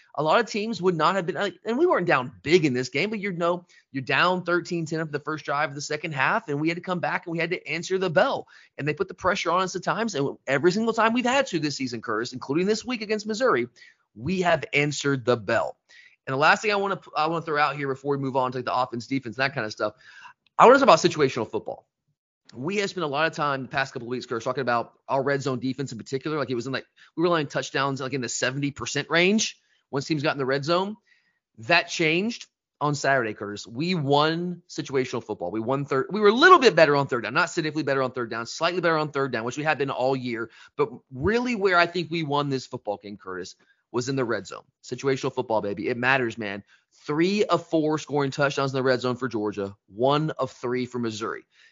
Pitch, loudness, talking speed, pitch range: 145 Hz, -24 LUFS, 260 wpm, 130-175 Hz